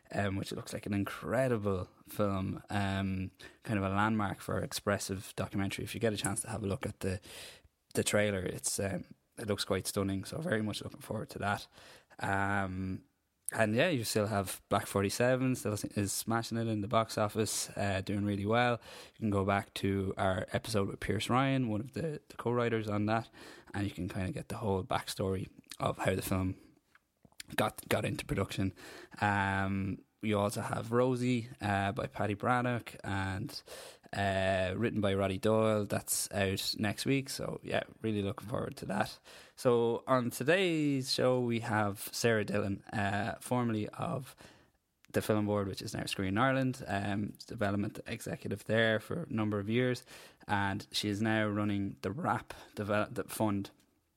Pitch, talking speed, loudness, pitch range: 105 Hz, 175 wpm, -34 LUFS, 100-115 Hz